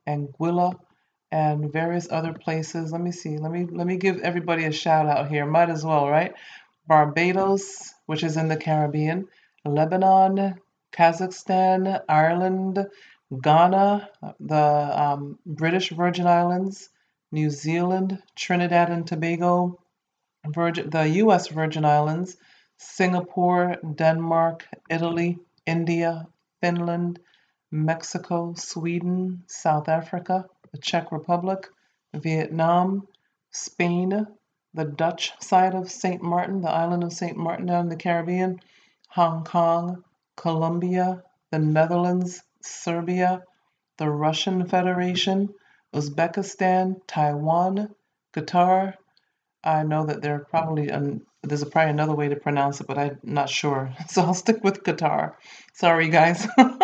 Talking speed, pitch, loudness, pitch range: 120 wpm, 170 Hz, -23 LUFS, 155-185 Hz